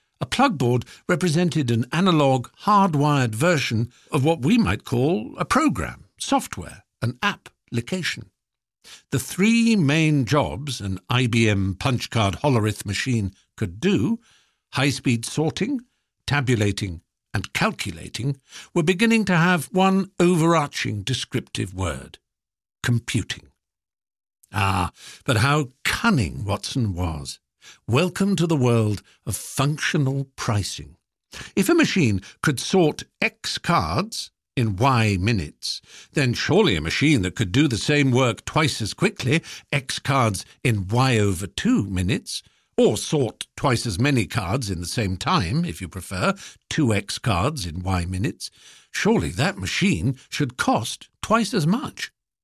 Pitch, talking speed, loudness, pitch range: 125 Hz, 130 wpm, -22 LUFS, 105-155 Hz